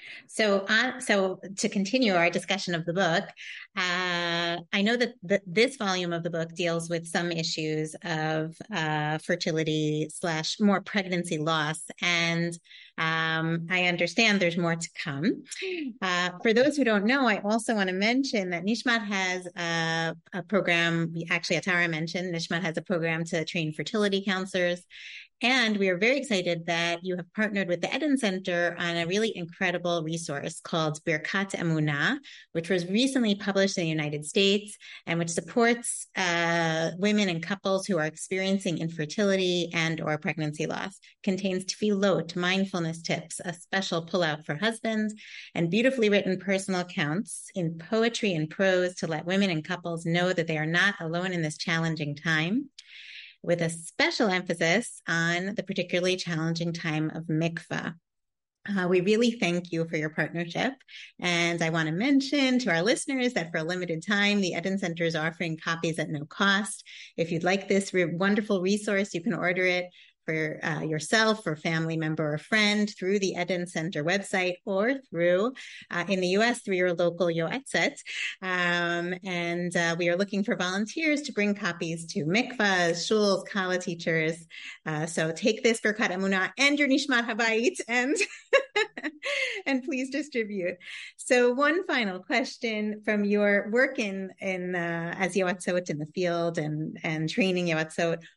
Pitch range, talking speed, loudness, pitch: 165-210 Hz, 165 wpm, -27 LUFS, 180 Hz